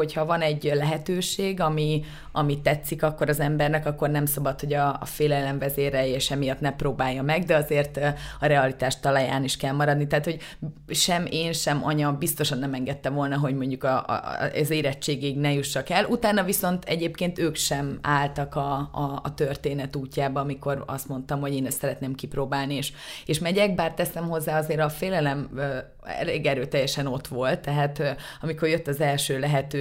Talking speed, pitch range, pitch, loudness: 190 wpm, 140-155 Hz, 145 Hz, -26 LUFS